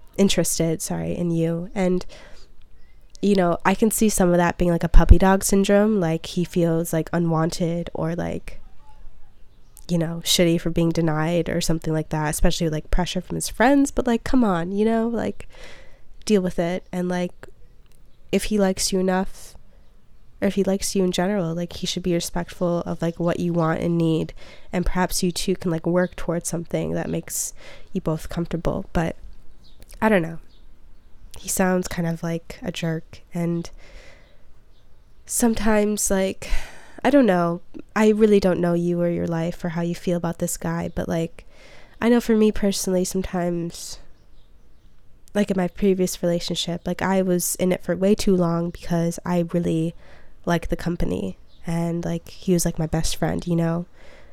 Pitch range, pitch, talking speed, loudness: 170-190 Hz, 175 Hz, 180 wpm, -22 LUFS